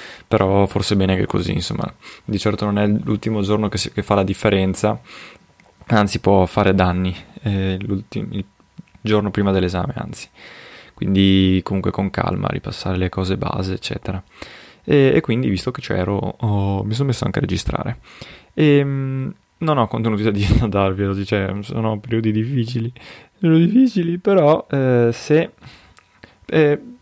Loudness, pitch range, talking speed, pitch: -19 LUFS, 95-120 Hz, 150 wpm, 105 Hz